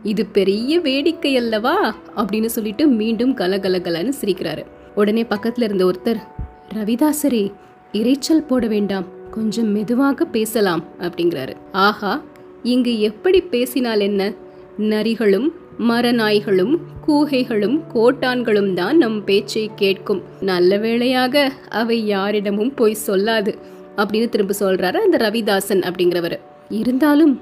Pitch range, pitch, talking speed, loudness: 195-250 Hz, 215 Hz, 85 wpm, -18 LUFS